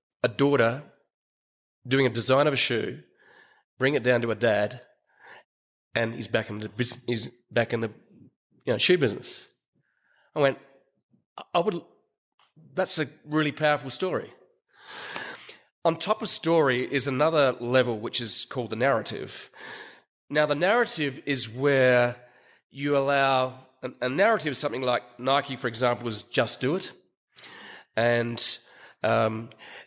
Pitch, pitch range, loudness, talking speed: 130 Hz, 120-150 Hz, -25 LUFS, 145 wpm